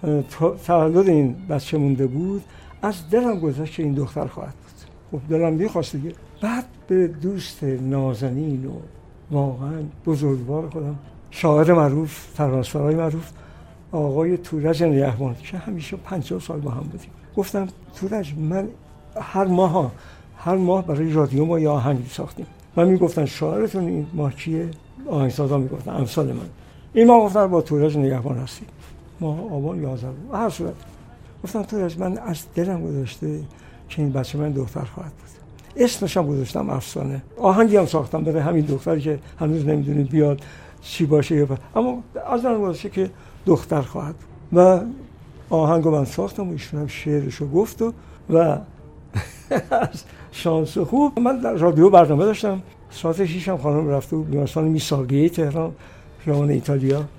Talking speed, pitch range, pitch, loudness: 150 wpm, 140-180 Hz, 155 Hz, -21 LUFS